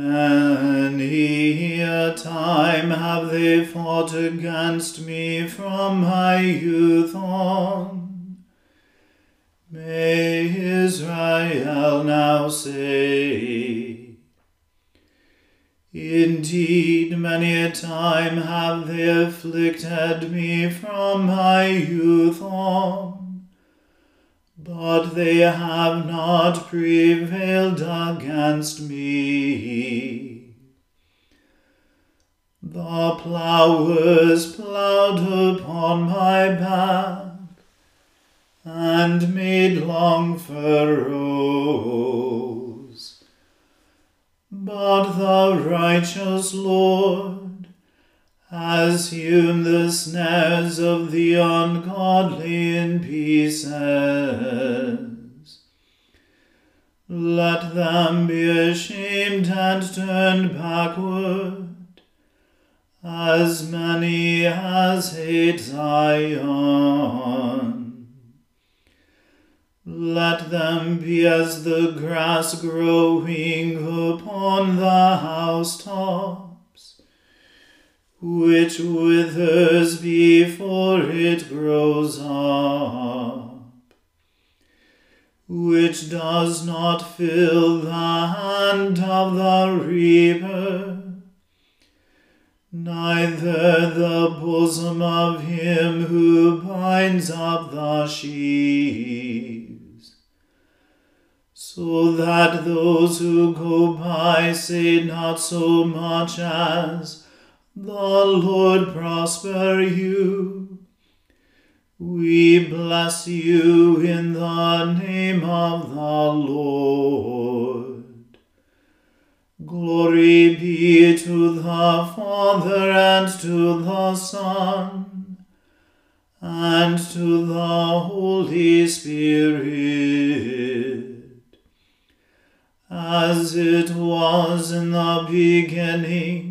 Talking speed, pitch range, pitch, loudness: 65 wpm, 165-180 Hz, 170 Hz, -19 LUFS